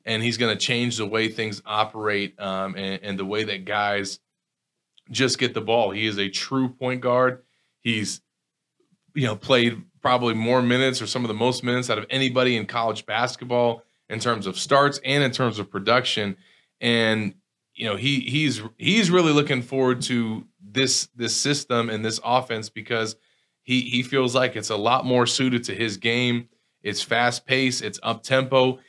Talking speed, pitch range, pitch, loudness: 185 wpm, 110-130 Hz, 120 Hz, -23 LUFS